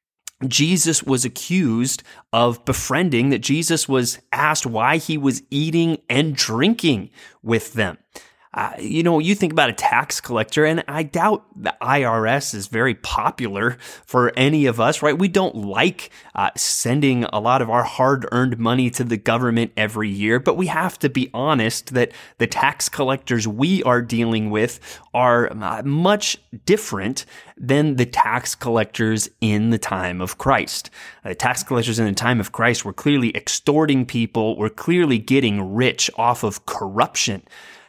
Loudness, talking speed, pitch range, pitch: -19 LUFS, 165 wpm, 115-150 Hz, 125 Hz